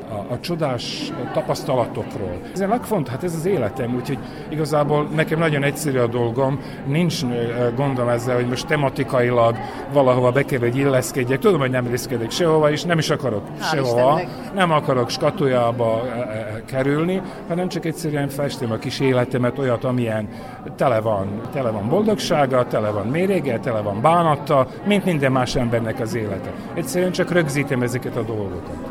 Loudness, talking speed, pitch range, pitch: -21 LUFS, 160 wpm, 120-155 Hz, 130 Hz